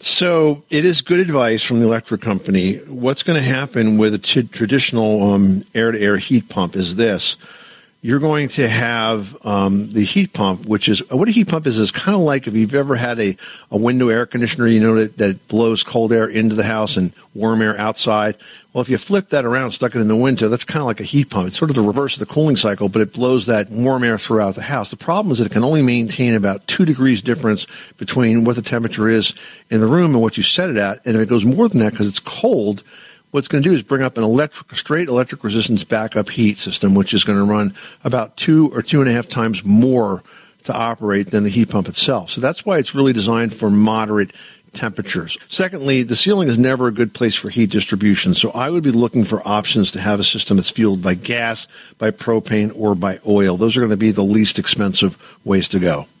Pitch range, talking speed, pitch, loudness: 105-130 Hz, 240 wpm, 115 Hz, -16 LUFS